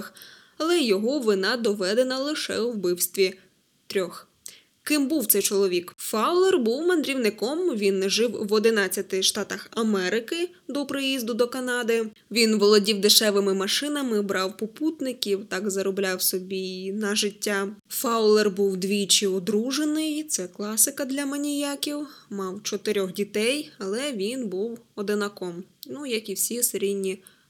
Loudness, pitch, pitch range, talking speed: -24 LUFS, 215 Hz, 195-260 Hz, 120 wpm